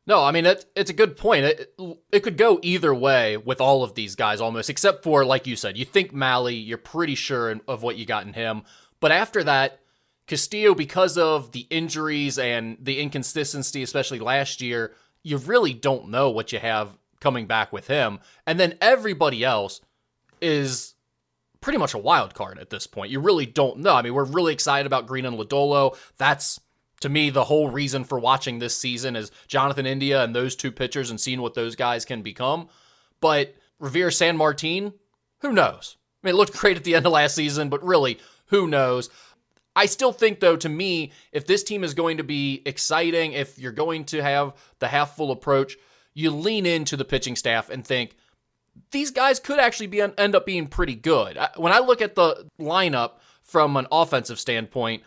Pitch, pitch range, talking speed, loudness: 140 Hz, 130-170 Hz, 200 wpm, -22 LUFS